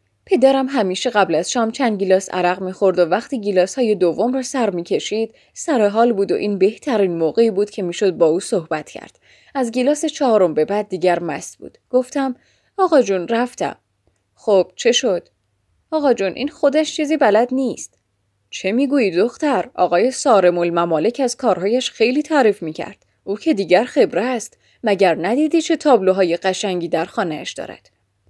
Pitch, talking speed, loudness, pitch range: 210 Hz, 165 wpm, -18 LUFS, 180-260 Hz